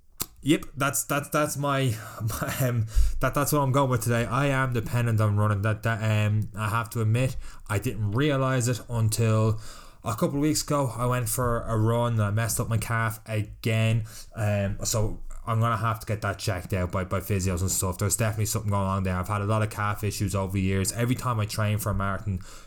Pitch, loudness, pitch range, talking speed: 110 Hz, -26 LUFS, 105-125 Hz, 230 wpm